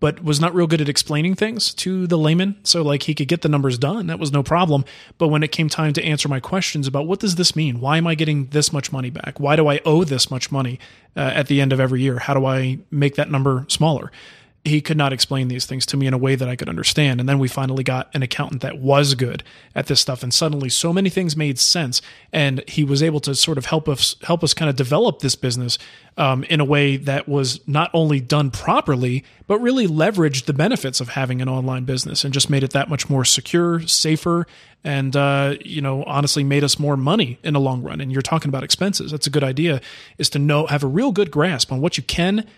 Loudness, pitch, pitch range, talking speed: -19 LUFS, 145 Hz, 135-160 Hz, 255 wpm